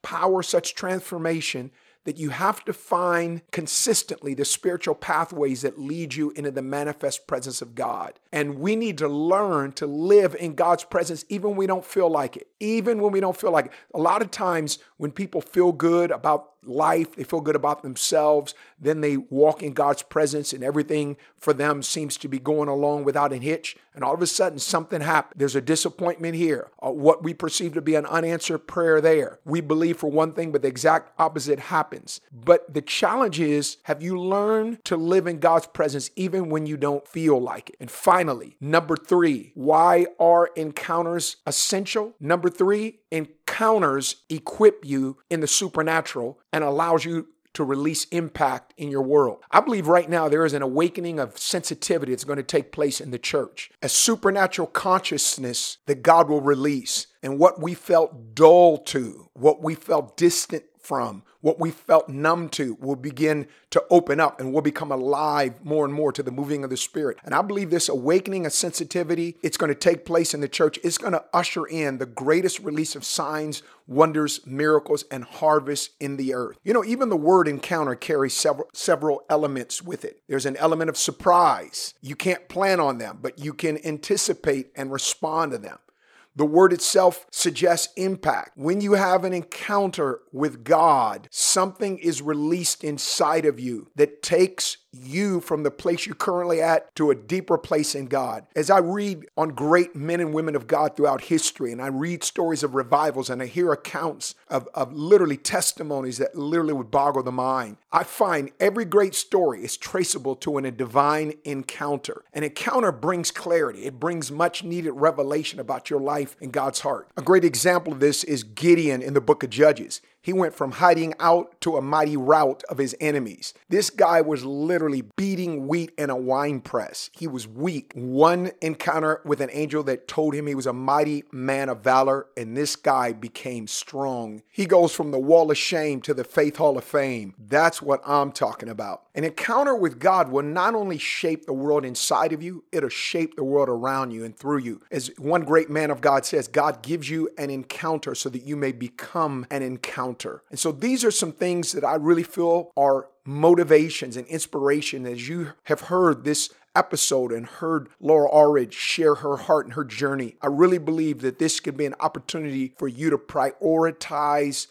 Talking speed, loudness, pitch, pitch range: 190 wpm, -23 LUFS, 155 Hz, 140-170 Hz